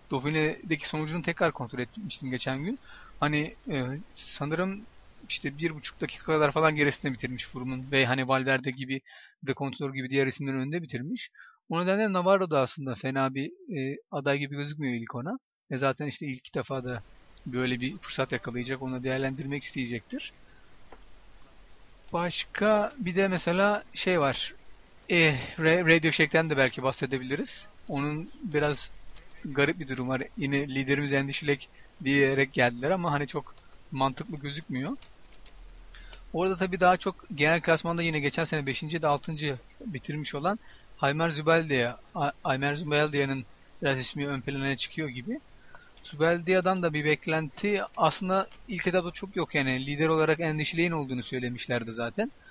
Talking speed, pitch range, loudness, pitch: 145 wpm, 135-170 Hz, -29 LUFS, 145 Hz